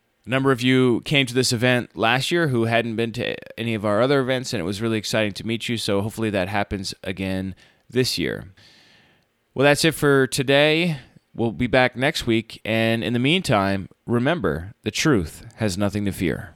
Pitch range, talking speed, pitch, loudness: 105-130 Hz, 200 wpm, 115 Hz, -21 LUFS